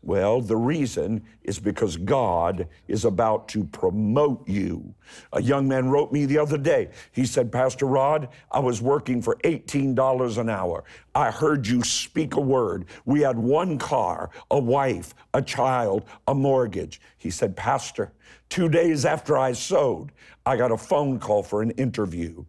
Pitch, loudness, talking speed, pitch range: 130 Hz, -24 LUFS, 165 wpm, 110-140 Hz